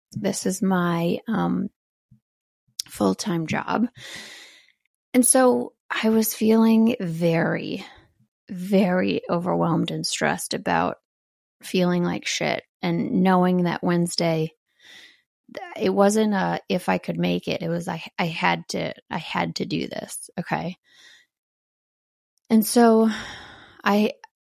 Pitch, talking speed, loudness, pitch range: 190 Hz, 120 wpm, -23 LUFS, 170-225 Hz